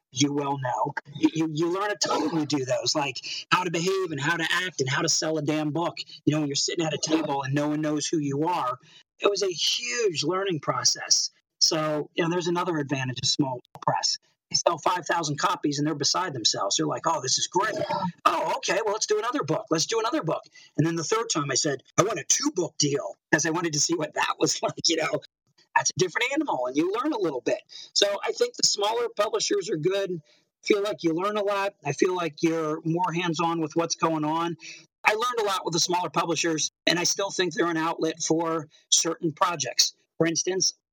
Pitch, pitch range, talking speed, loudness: 165 Hz, 155-190 Hz, 240 wpm, -25 LUFS